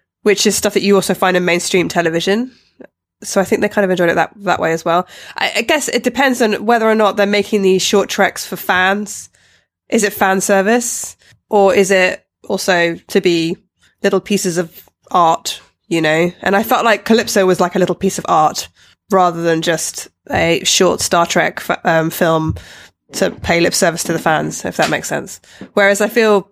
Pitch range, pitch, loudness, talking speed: 175-210 Hz, 195 Hz, -14 LUFS, 205 wpm